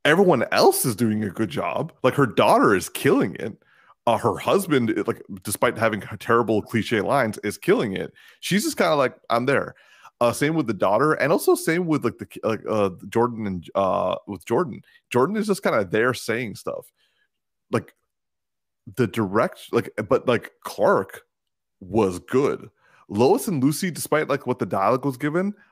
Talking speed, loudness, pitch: 180 wpm, -22 LUFS, 140 Hz